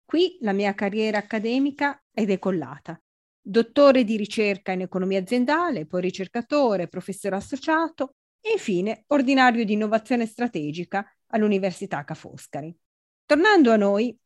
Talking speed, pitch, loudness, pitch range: 120 wpm, 215 Hz, -23 LUFS, 190-265 Hz